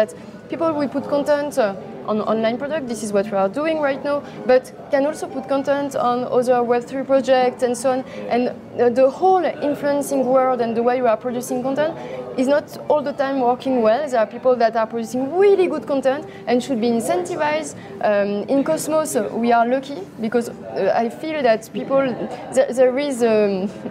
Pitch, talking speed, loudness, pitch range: 255 Hz, 200 wpm, -20 LUFS, 235-285 Hz